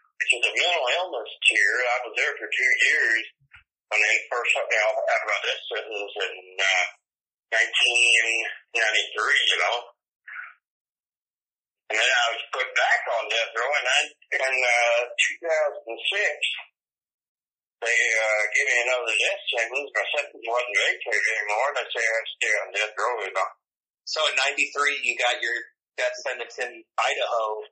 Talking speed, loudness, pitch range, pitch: 155 wpm, -23 LUFS, 115-145 Hz, 120 Hz